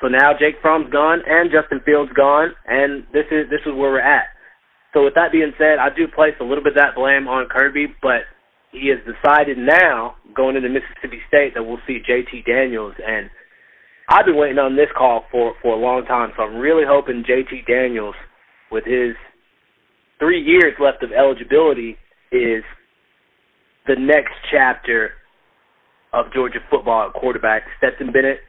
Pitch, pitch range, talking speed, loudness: 140 Hz, 125-150 Hz, 175 wpm, -16 LUFS